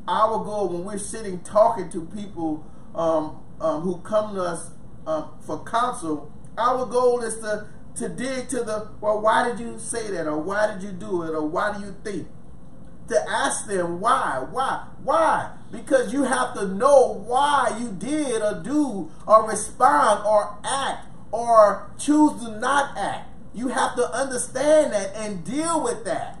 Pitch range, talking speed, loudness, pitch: 185-245 Hz, 175 wpm, -23 LUFS, 215 Hz